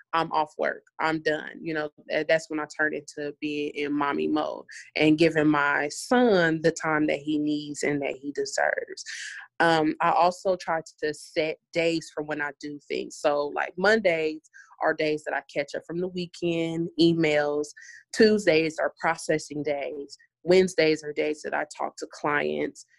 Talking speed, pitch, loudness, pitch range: 170 wpm, 155 Hz, -26 LUFS, 150-170 Hz